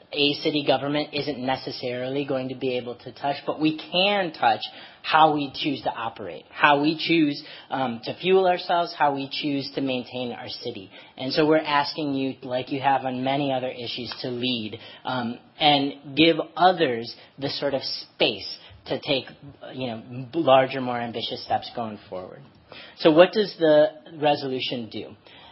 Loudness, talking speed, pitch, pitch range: -24 LUFS, 170 wpm, 140 Hz, 130-155 Hz